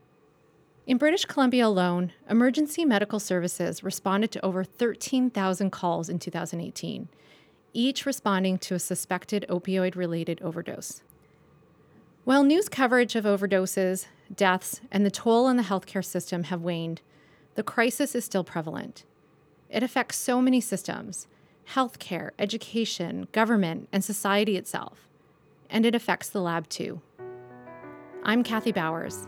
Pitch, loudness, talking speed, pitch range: 195 Hz, -27 LUFS, 125 wpm, 180-235 Hz